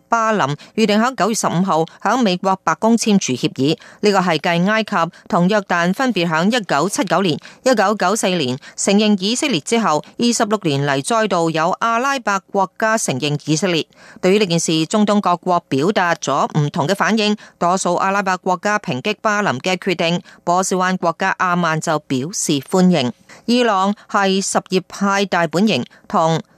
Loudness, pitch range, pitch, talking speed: -17 LUFS, 170-215 Hz, 190 Hz, 270 characters per minute